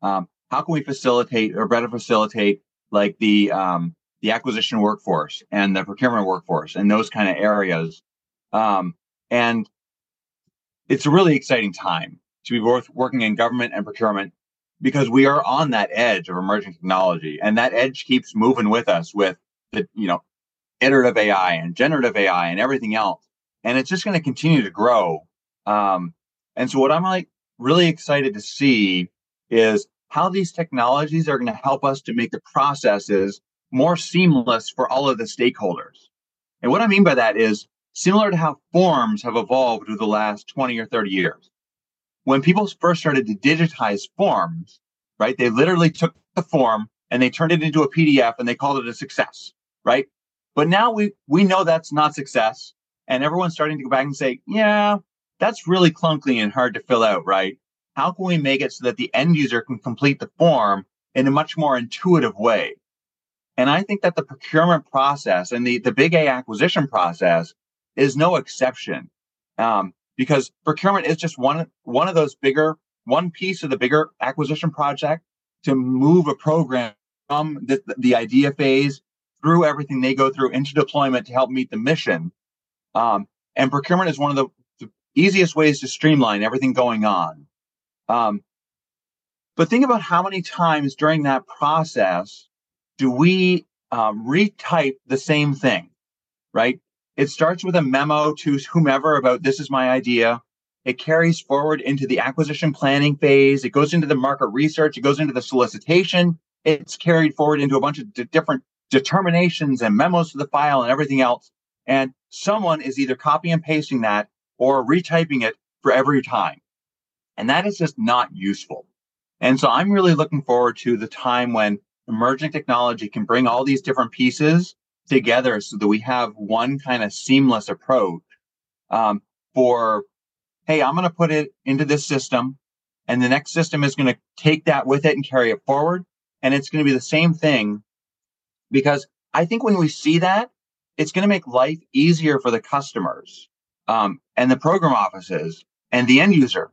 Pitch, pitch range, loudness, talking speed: 140 Hz, 125-160 Hz, -19 LUFS, 180 wpm